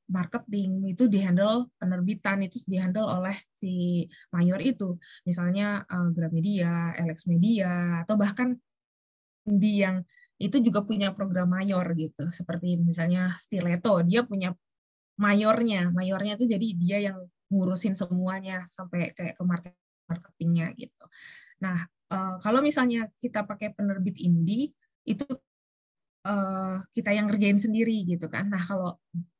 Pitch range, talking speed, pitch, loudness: 175-210 Hz, 125 wpm, 190 Hz, -28 LUFS